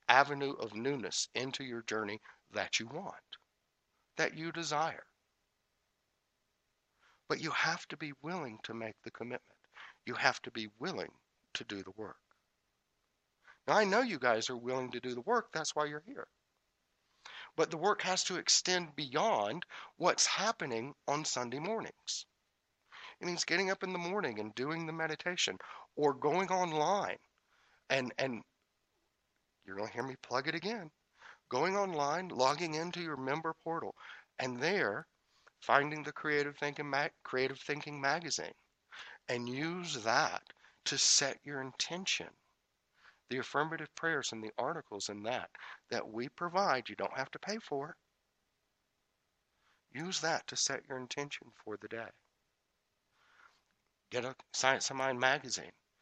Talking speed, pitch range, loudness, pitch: 150 wpm, 130-165 Hz, -35 LUFS, 145 Hz